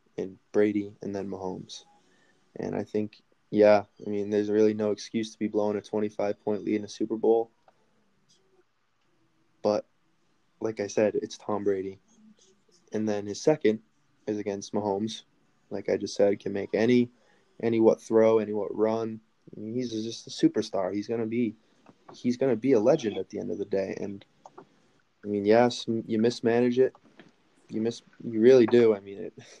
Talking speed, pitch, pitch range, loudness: 175 wpm, 110 Hz, 105-115 Hz, -27 LUFS